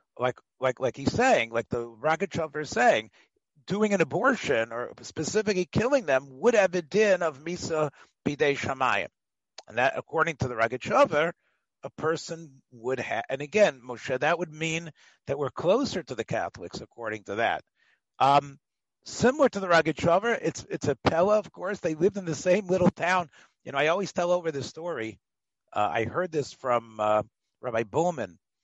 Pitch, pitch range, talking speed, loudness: 155 Hz, 125-180 Hz, 175 wpm, -27 LUFS